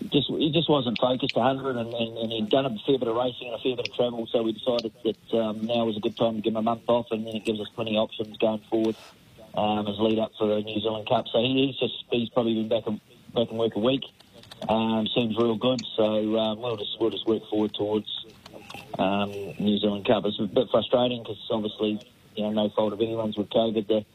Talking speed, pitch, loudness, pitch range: 255 wpm, 115 Hz, -26 LUFS, 110-120 Hz